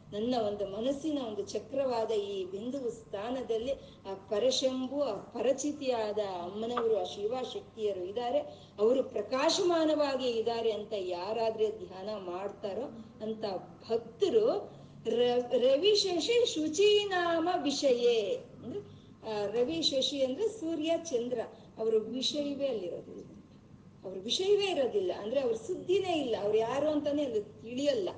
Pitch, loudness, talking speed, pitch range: 250 Hz, -32 LUFS, 110 wpm, 220-325 Hz